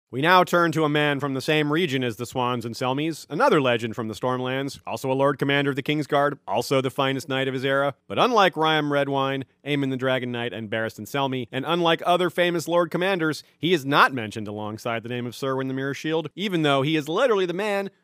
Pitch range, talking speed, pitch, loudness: 125-160 Hz, 235 wpm, 140 Hz, -23 LUFS